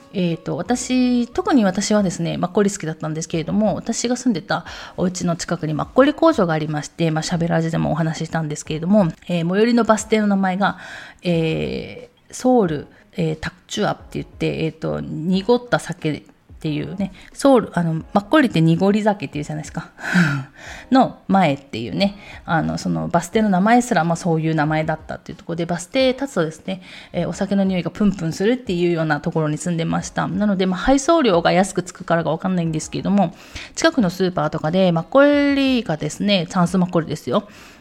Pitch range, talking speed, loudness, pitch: 160-210 Hz, 415 characters per minute, -20 LUFS, 175 Hz